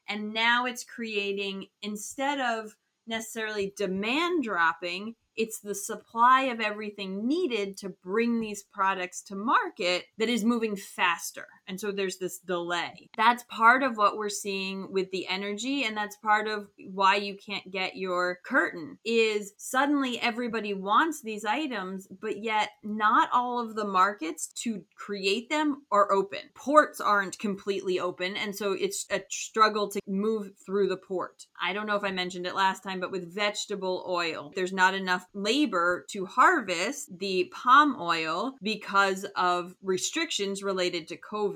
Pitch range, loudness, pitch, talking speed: 190-225 Hz, -28 LUFS, 205 Hz, 155 wpm